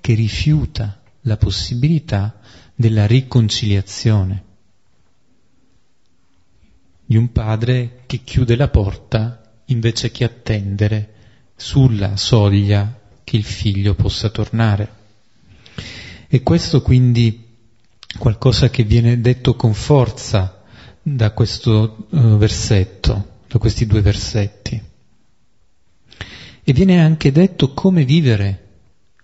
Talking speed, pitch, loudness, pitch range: 90 wpm, 110 Hz, -16 LUFS, 100-125 Hz